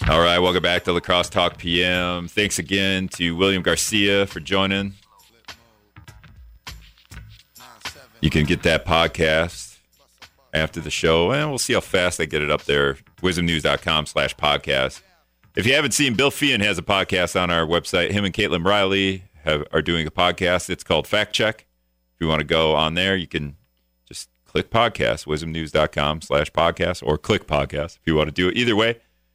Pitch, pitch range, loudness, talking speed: 85 Hz, 80-95 Hz, -20 LUFS, 180 wpm